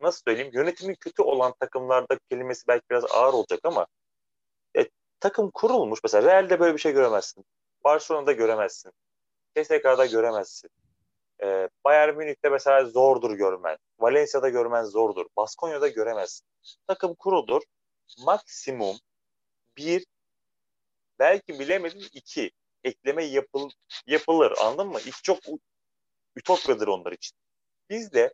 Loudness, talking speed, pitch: -24 LUFS, 120 wpm, 180 Hz